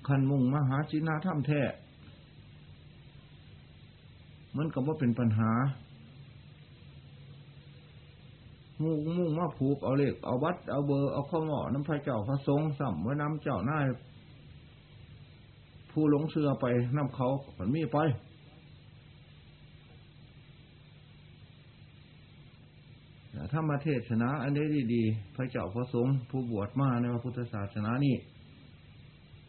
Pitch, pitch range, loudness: 140 Hz, 125-145 Hz, -31 LUFS